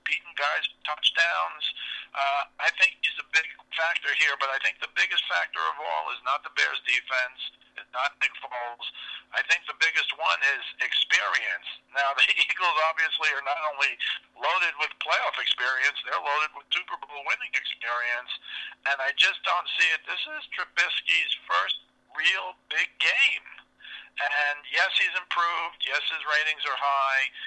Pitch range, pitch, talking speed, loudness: 135-160 Hz, 150 Hz, 165 wpm, -25 LUFS